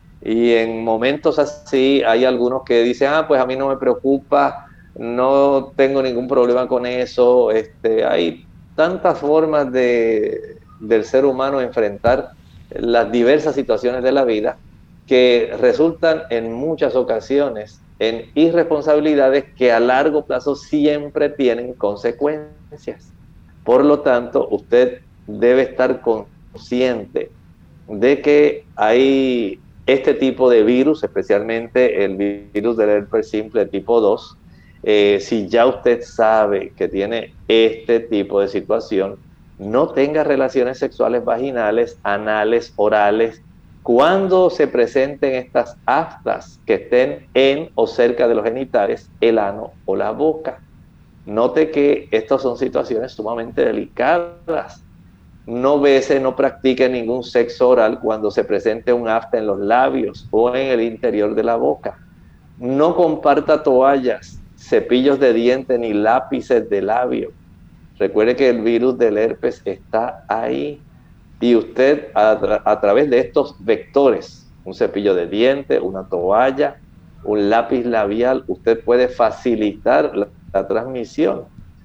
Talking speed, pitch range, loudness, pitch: 130 wpm, 115-140 Hz, -17 LUFS, 125 Hz